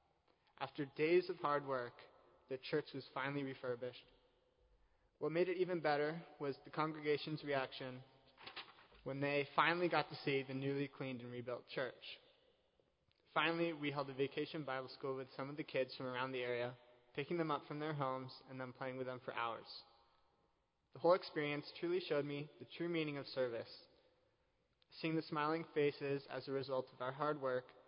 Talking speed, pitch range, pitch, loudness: 175 wpm, 130-155 Hz, 140 Hz, -42 LUFS